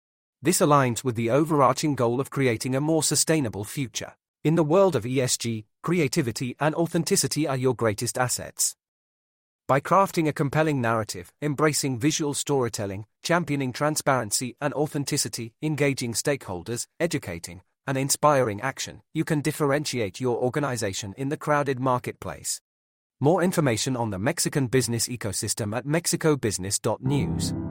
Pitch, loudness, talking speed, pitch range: 135 Hz, -25 LUFS, 130 wpm, 115-150 Hz